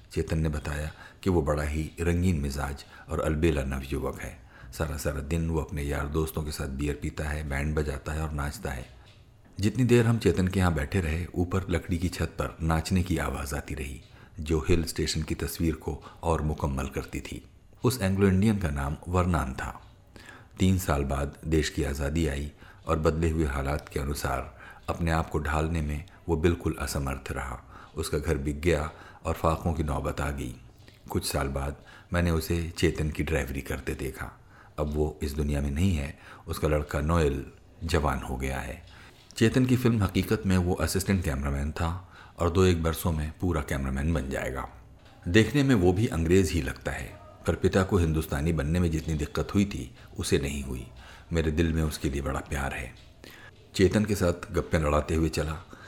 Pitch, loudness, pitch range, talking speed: 80 Hz, -29 LUFS, 75-90 Hz, 190 wpm